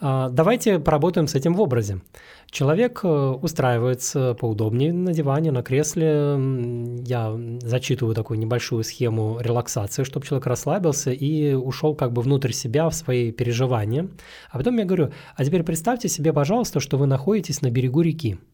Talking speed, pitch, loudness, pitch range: 150 wpm, 135 Hz, -22 LUFS, 120-160 Hz